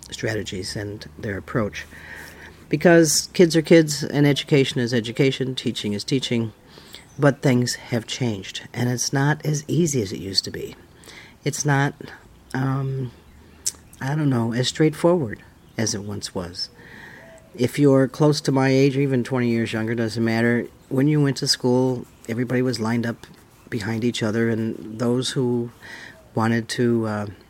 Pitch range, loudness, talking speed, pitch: 110-140 Hz, -22 LUFS, 155 wpm, 120 Hz